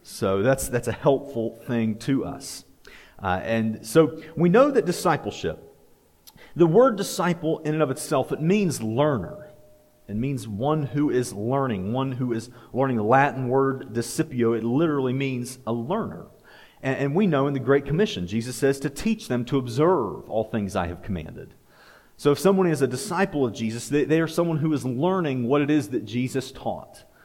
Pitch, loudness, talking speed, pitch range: 135 Hz, -24 LUFS, 185 wpm, 120-155 Hz